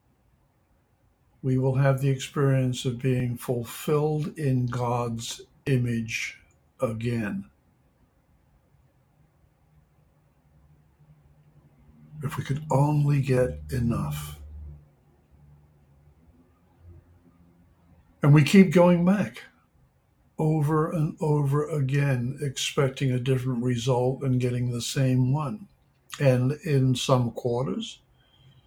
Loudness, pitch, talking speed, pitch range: -25 LUFS, 125 Hz, 85 wpm, 85-140 Hz